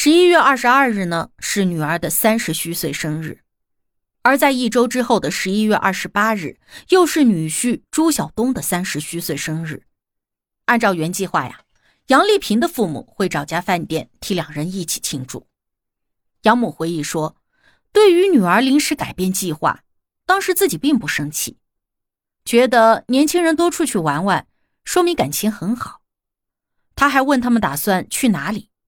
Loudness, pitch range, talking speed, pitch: -17 LUFS, 165-270 Hz, 245 characters per minute, 210 Hz